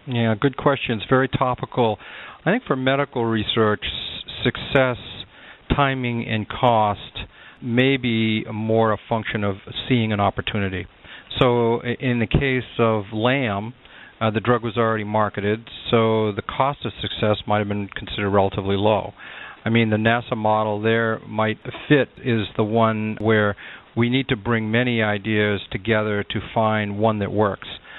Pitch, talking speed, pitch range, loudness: 110 Hz, 150 wpm, 105-120 Hz, -21 LUFS